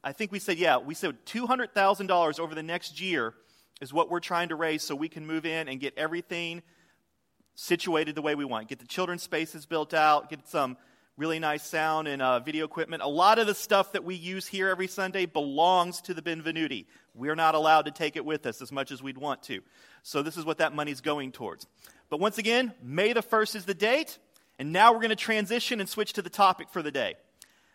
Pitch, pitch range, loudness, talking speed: 165 Hz, 150-190 Hz, -28 LUFS, 230 wpm